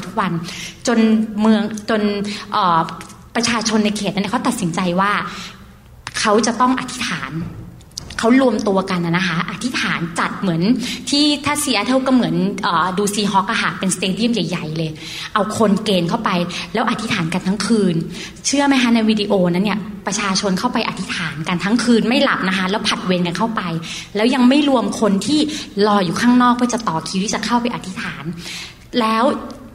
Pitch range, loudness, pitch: 185-235 Hz, -18 LUFS, 210 Hz